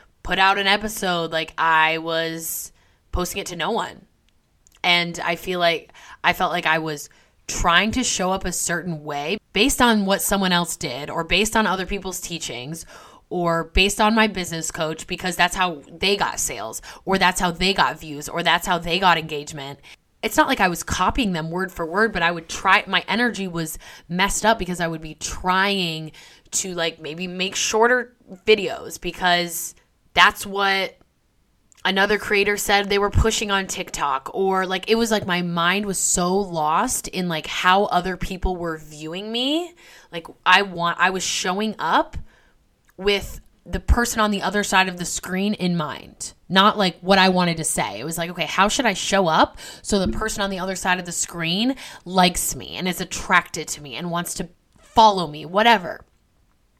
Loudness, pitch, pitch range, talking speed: -21 LUFS, 185 Hz, 170-200 Hz, 190 wpm